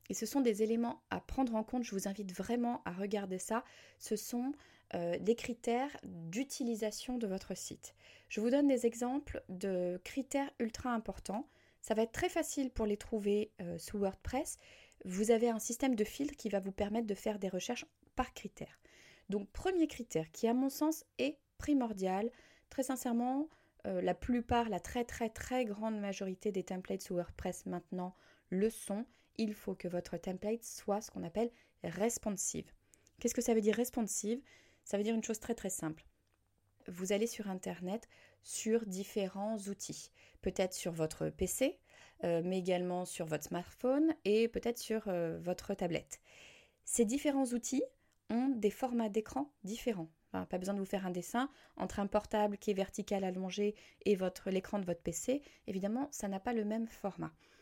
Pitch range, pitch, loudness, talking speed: 190-240 Hz, 215 Hz, -38 LUFS, 180 wpm